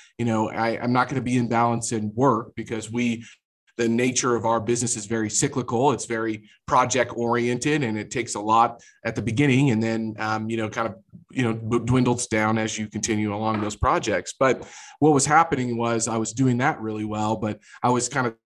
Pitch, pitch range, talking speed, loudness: 115 Hz, 110-125 Hz, 220 wpm, -23 LUFS